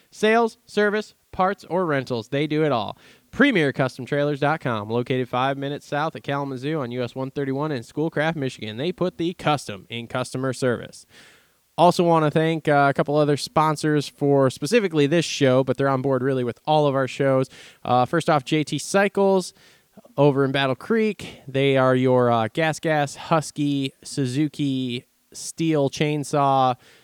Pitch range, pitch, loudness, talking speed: 130-160 Hz, 145 Hz, -22 LUFS, 160 wpm